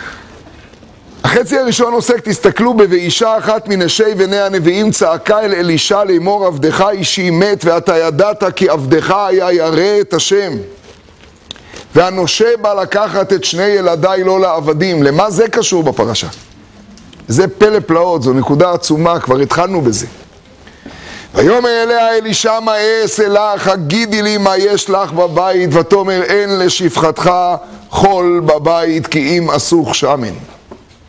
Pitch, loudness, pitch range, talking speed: 190 Hz, -11 LUFS, 170-205 Hz, 130 wpm